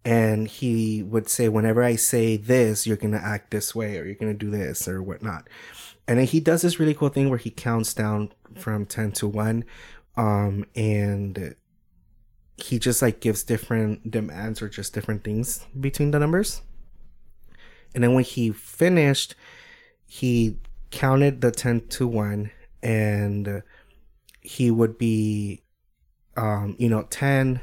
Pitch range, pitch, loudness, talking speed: 105-125 Hz, 110 Hz, -24 LUFS, 155 wpm